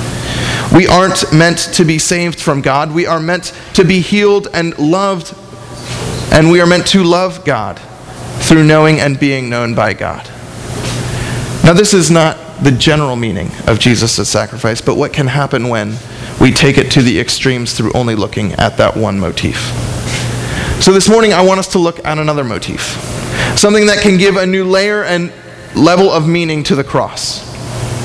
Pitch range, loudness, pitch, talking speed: 120-180 Hz, -11 LUFS, 150 Hz, 180 wpm